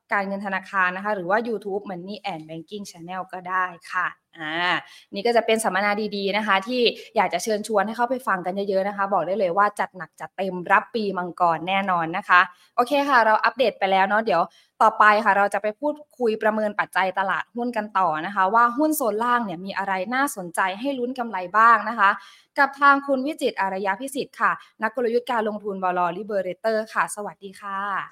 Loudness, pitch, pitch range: -22 LUFS, 200 Hz, 185-230 Hz